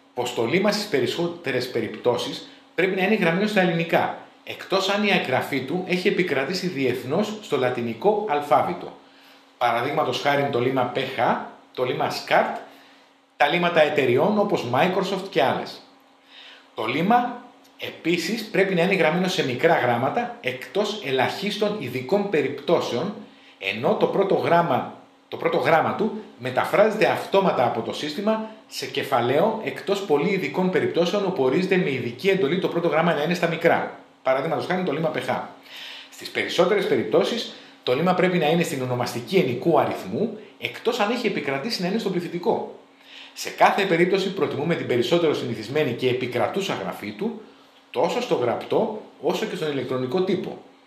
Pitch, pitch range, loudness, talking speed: 175 Hz, 135-200 Hz, -23 LUFS, 150 wpm